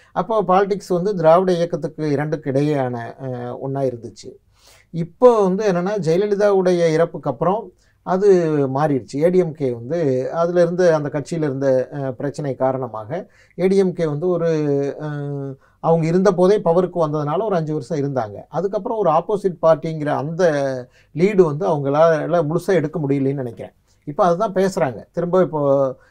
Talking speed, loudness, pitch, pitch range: 125 wpm, -19 LUFS, 160 Hz, 135-180 Hz